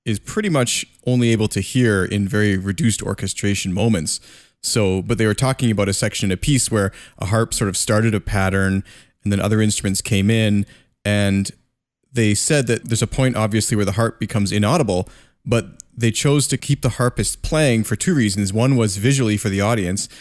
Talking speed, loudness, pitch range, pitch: 200 wpm, -19 LUFS, 100-120 Hz, 110 Hz